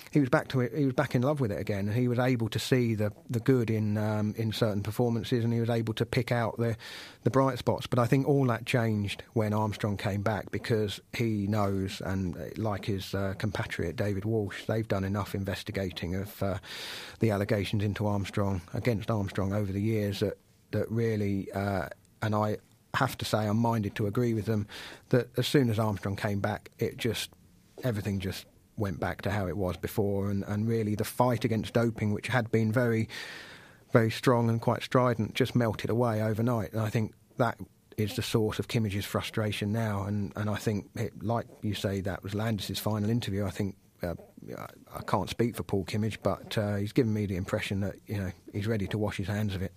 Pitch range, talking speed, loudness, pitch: 100-115 Hz, 210 wpm, -30 LUFS, 110 Hz